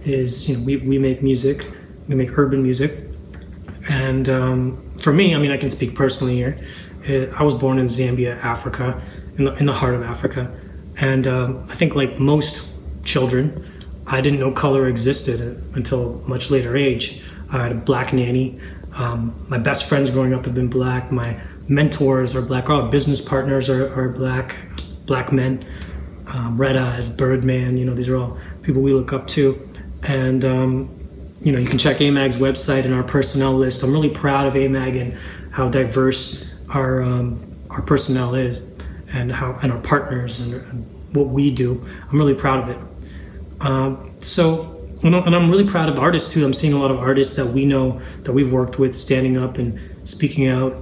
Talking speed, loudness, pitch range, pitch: 190 wpm, -19 LUFS, 125-135 Hz, 130 Hz